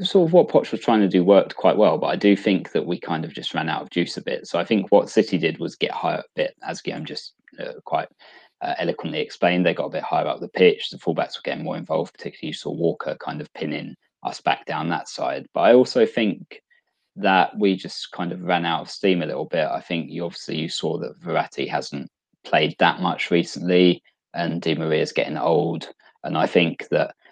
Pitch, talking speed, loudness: 100 Hz, 240 wpm, -22 LUFS